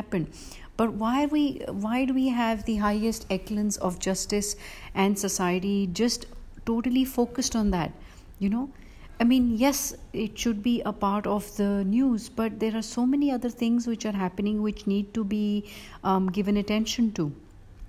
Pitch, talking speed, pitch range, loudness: 215 Hz, 170 wpm, 200-235 Hz, -27 LUFS